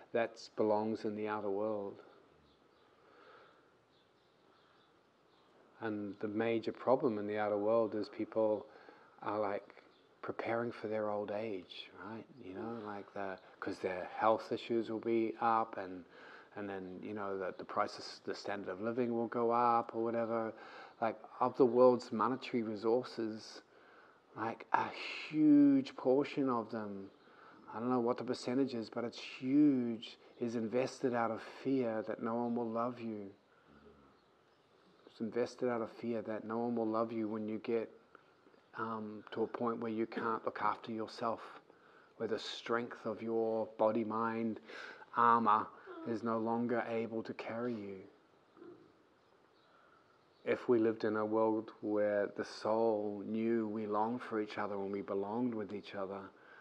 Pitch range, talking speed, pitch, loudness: 105-120 Hz, 155 wpm, 115 Hz, -37 LUFS